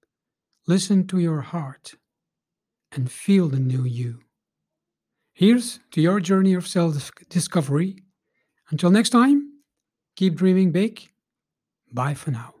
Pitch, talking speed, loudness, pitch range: 180 Hz, 120 wpm, -21 LUFS, 145-195 Hz